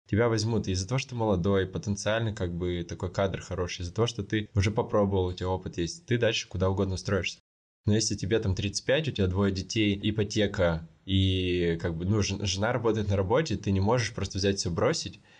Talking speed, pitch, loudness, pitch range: 210 wpm, 100 Hz, -28 LUFS, 95-110 Hz